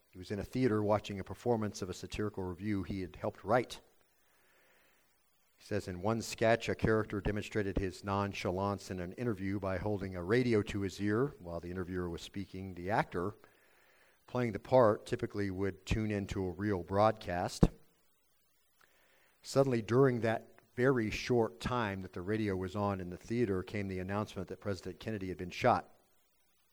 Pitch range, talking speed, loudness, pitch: 95-110 Hz, 170 wpm, -35 LUFS, 100 Hz